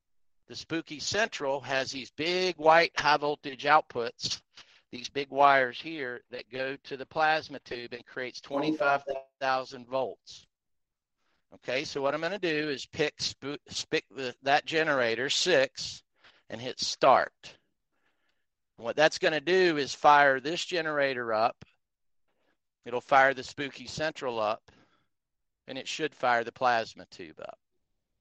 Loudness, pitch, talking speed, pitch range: -28 LUFS, 140 Hz, 140 wpm, 130-155 Hz